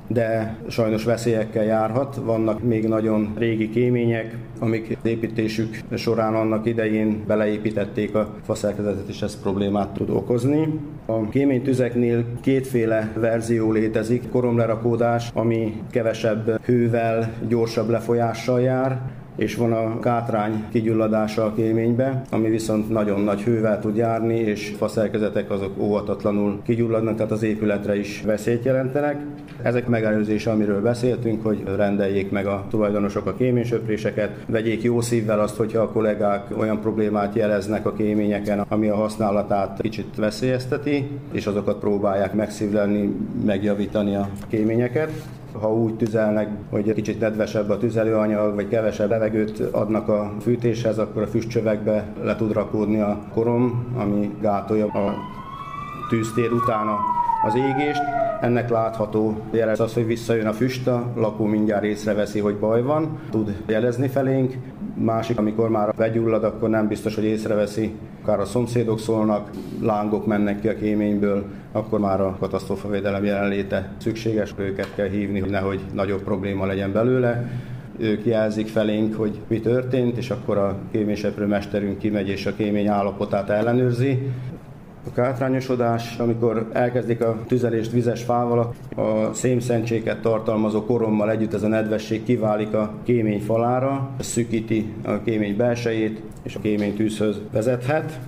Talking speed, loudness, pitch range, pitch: 140 wpm, -22 LUFS, 105-120 Hz, 110 Hz